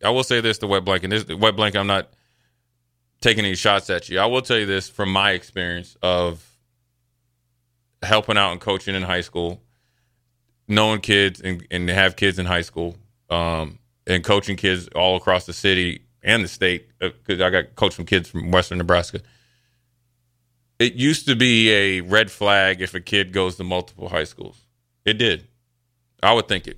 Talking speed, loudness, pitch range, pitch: 190 wpm, -20 LUFS, 90-120 Hz, 100 Hz